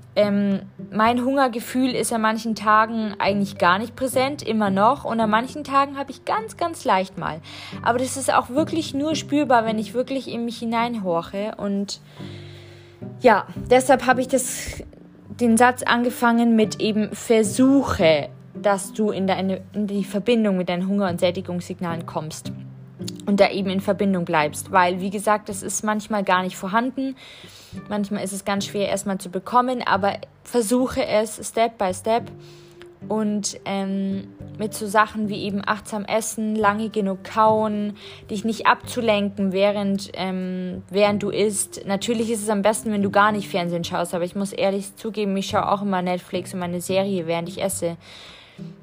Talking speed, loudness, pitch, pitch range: 170 wpm, -22 LUFS, 205 Hz, 190-230 Hz